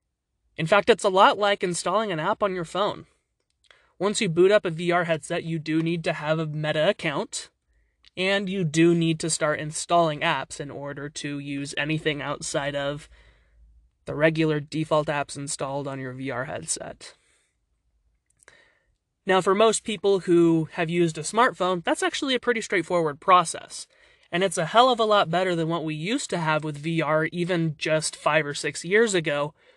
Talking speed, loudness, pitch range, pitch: 180 wpm, -24 LUFS, 145-185 Hz, 165 Hz